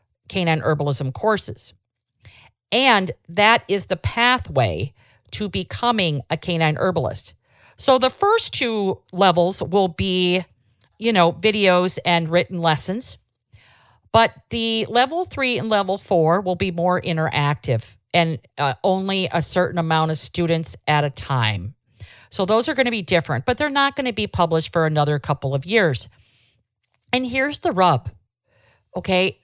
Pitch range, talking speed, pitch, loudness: 130-195 Hz, 145 wpm, 170 Hz, -20 LUFS